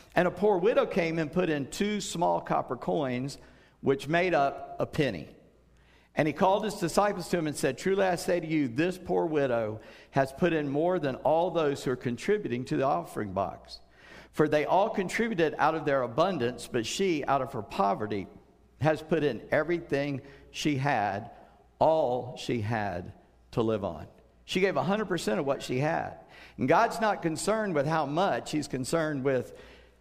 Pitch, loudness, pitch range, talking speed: 155 Hz, -29 LUFS, 130-175 Hz, 180 wpm